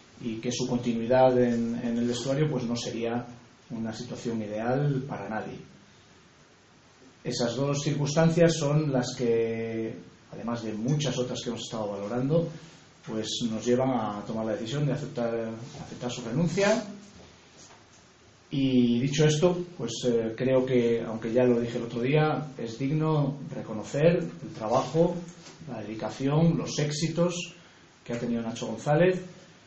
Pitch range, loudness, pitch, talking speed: 115-150 Hz, -28 LUFS, 125 Hz, 140 wpm